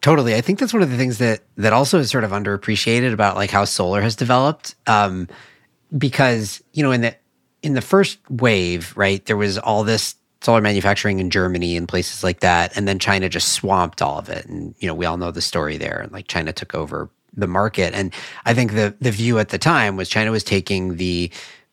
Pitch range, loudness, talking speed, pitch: 95-120 Hz, -19 LUFS, 225 wpm, 105 Hz